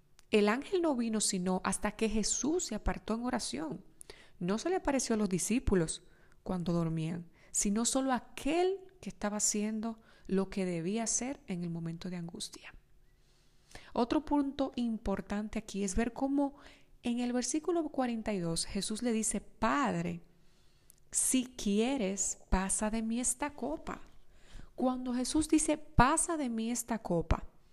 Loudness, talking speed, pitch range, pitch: -33 LUFS, 145 wpm, 195-265 Hz, 225 Hz